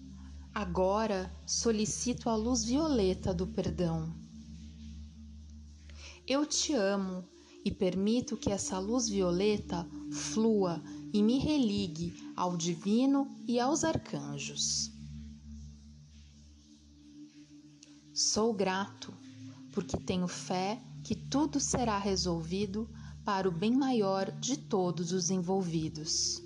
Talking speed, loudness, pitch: 95 wpm, -32 LUFS, 185 Hz